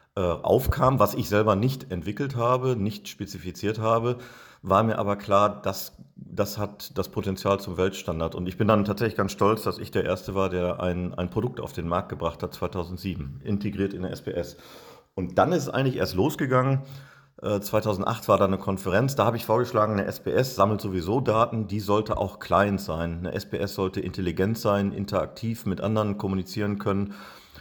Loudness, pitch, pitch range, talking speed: -26 LUFS, 100 Hz, 95-110 Hz, 180 wpm